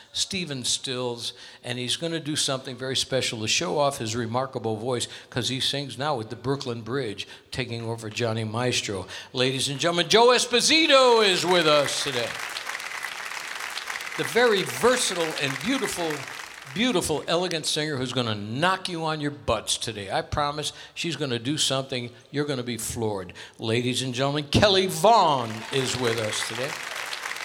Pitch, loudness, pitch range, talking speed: 130 Hz, -25 LUFS, 120-155 Hz, 155 wpm